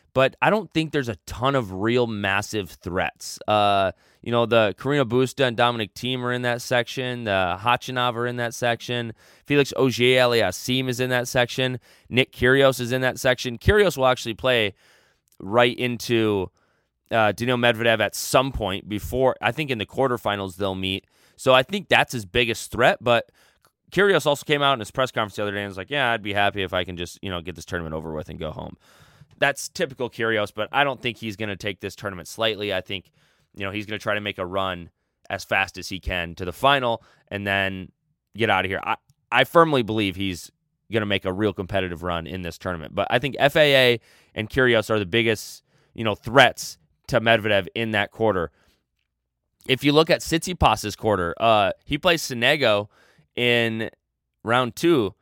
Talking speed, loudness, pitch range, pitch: 200 wpm, -22 LUFS, 95-125 Hz, 115 Hz